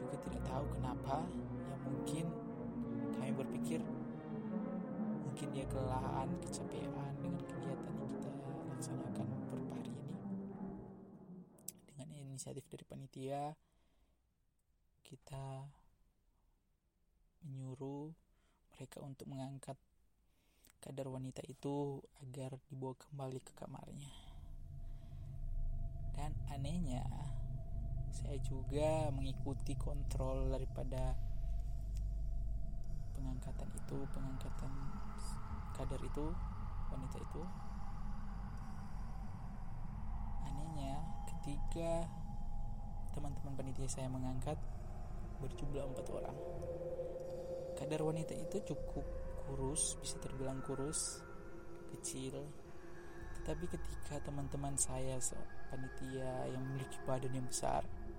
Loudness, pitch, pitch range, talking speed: -45 LUFS, 135 Hz, 125-145 Hz, 80 wpm